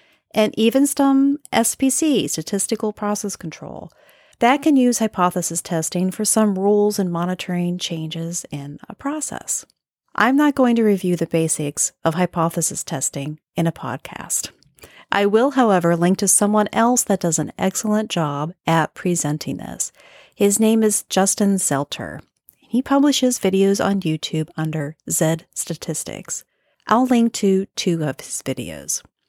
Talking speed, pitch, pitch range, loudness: 140 wpm, 190 Hz, 165-225 Hz, -19 LUFS